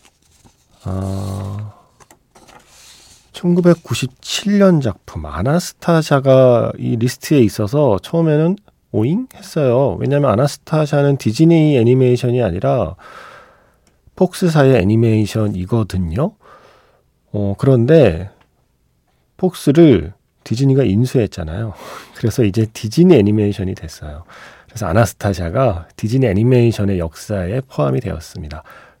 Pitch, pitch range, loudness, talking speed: 120 Hz, 100-140 Hz, -15 LUFS, 260 characters per minute